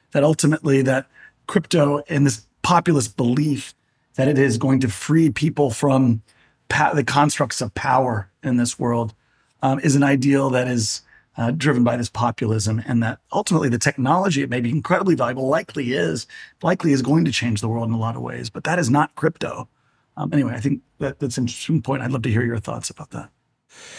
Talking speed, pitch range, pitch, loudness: 205 wpm, 120-145 Hz, 135 Hz, -20 LUFS